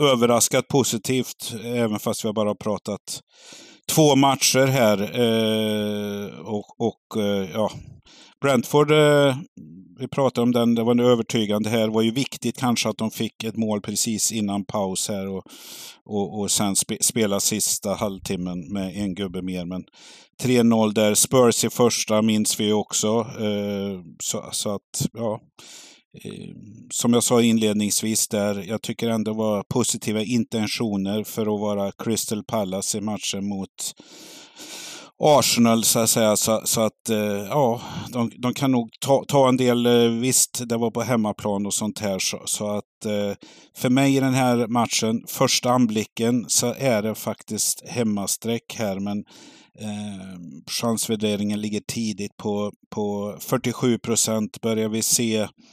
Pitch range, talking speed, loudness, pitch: 105-120 Hz, 155 wpm, -22 LUFS, 110 Hz